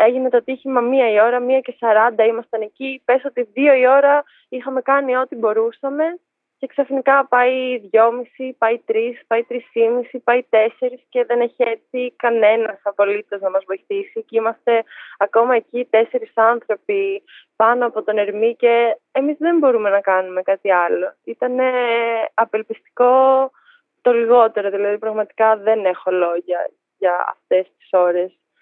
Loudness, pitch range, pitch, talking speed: -18 LUFS, 220-260 Hz, 240 Hz, 165 wpm